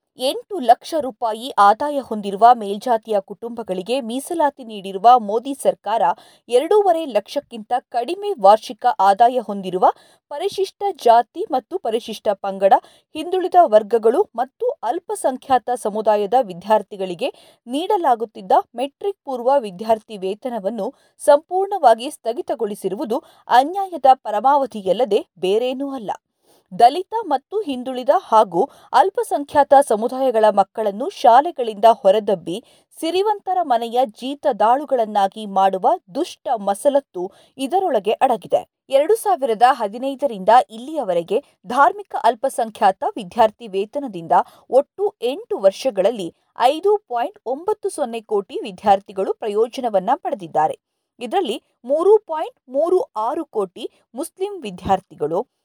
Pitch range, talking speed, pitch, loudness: 220-340 Hz, 90 wpm, 260 Hz, -19 LUFS